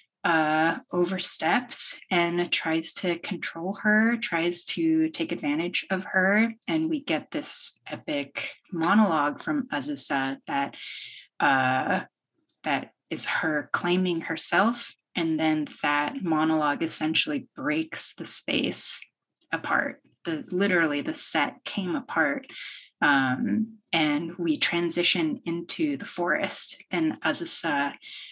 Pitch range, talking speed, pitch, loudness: 160-235 Hz, 110 wpm, 175 Hz, -25 LUFS